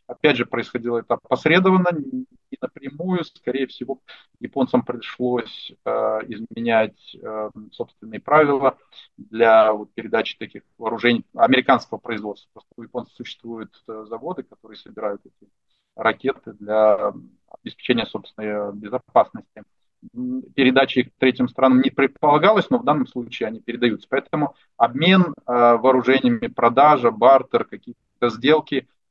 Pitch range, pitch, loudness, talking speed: 115-140 Hz, 125 Hz, -20 LUFS, 120 wpm